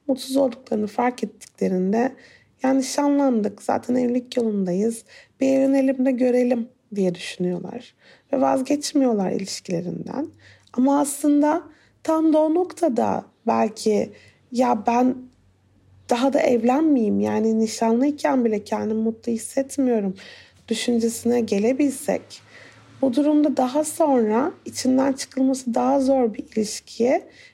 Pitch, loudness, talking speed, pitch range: 250 Hz, -22 LUFS, 100 wpm, 225-275 Hz